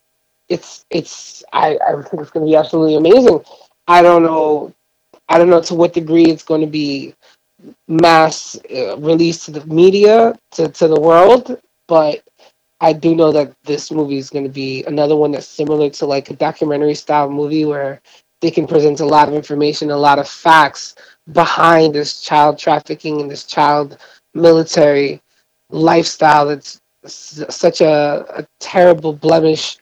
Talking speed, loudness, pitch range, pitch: 165 wpm, -13 LUFS, 150-165 Hz, 155 Hz